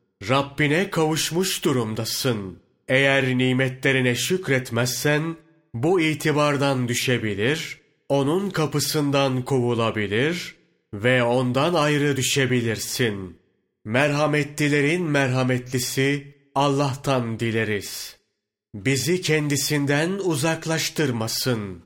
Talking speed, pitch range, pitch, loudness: 65 wpm, 125-150 Hz, 135 Hz, -22 LUFS